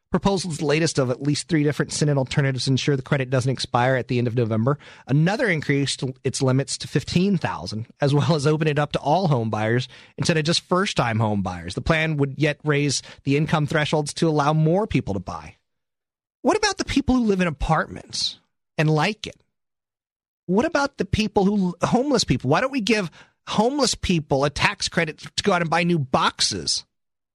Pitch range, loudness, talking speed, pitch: 135-180 Hz, -22 LUFS, 200 wpm, 150 Hz